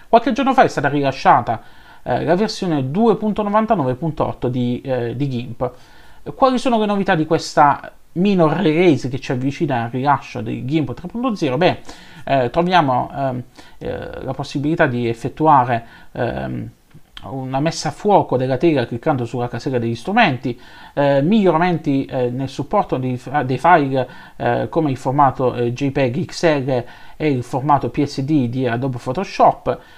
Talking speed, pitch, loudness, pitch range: 145 wpm, 140 Hz, -18 LUFS, 125-170 Hz